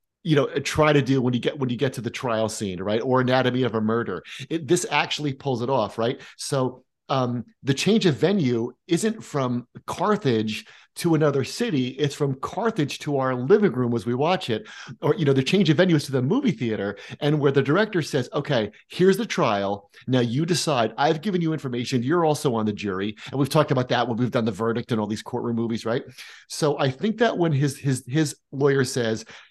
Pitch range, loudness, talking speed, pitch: 120-150 Hz, -23 LUFS, 225 wpm, 135 Hz